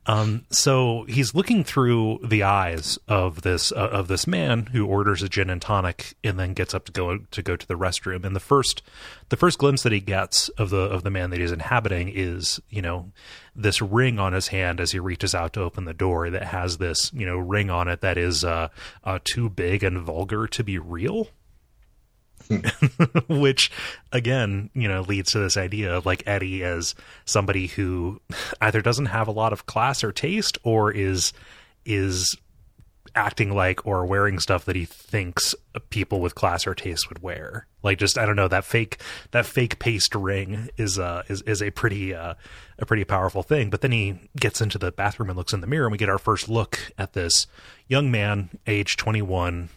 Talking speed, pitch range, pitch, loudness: 205 wpm, 90-110 Hz, 100 Hz, -24 LUFS